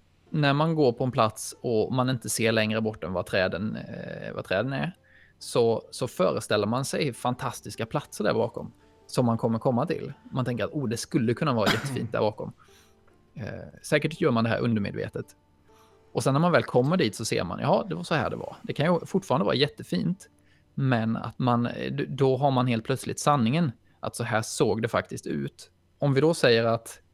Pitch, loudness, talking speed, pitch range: 120 Hz, -27 LUFS, 210 wpm, 110-140 Hz